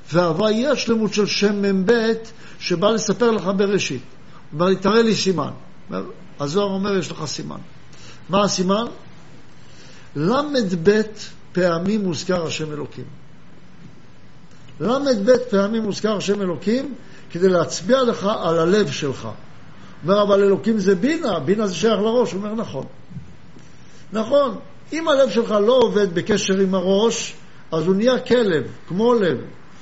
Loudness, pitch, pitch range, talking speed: -20 LUFS, 200 Hz, 175-225 Hz, 130 wpm